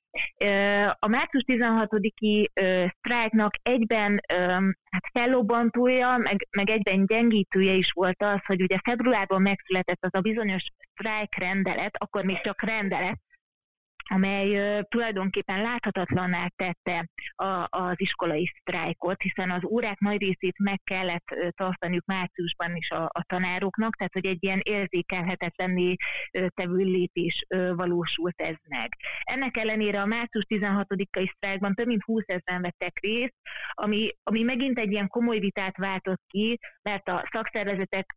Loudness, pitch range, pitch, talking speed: -27 LUFS, 185-215 Hz, 195 Hz, 125 wpm